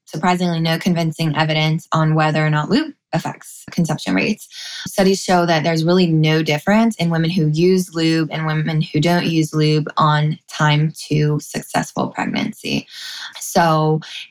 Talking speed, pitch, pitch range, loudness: 150 wpm, 160 Hz, 155-180 Hz, -18 LUFS